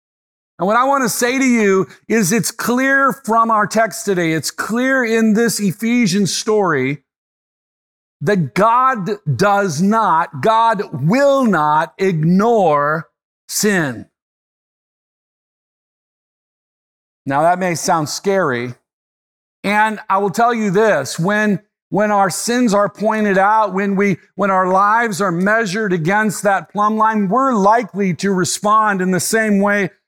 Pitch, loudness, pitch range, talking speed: 205 Hz, -15 LUFS, 180-220 Hz, 135 wpm